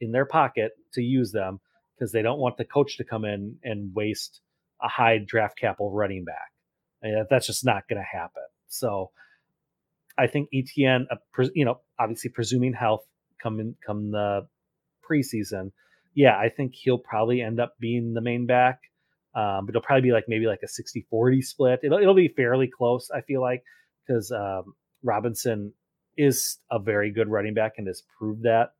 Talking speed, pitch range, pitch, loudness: 190 wpm, 110-130 Hz, 120 Hz, -25 LUFS